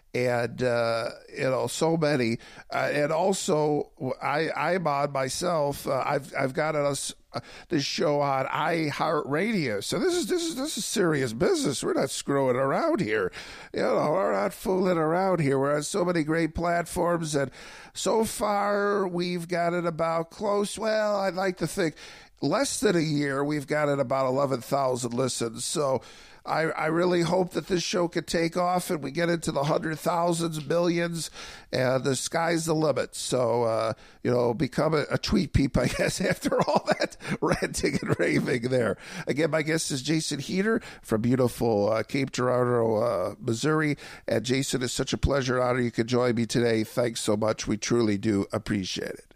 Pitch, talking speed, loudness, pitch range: 150 Hz, 180 wpm, -26 LUFS, 125-175 Hz